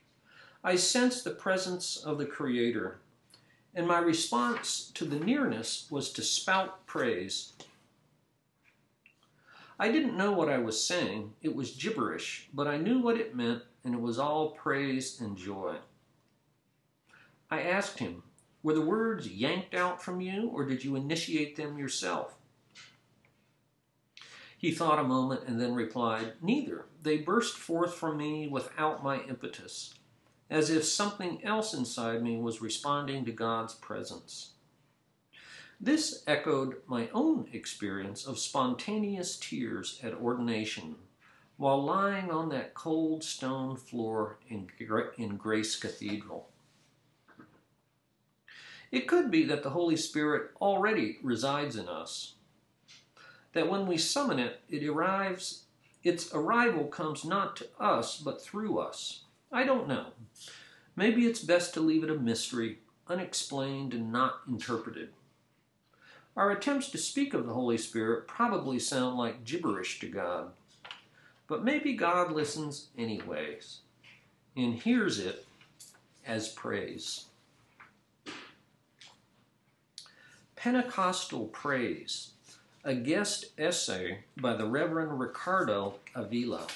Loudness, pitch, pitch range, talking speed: -32 LUFS, 150 Hz, 120-190 Hz, 125 wpm